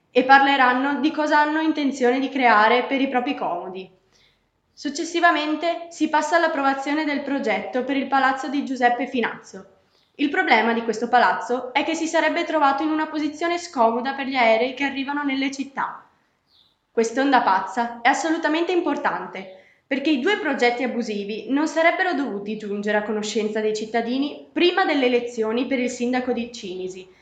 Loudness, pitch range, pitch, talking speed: -21 LUFS, 230-300 Hz, 265 Hz, 155 wpm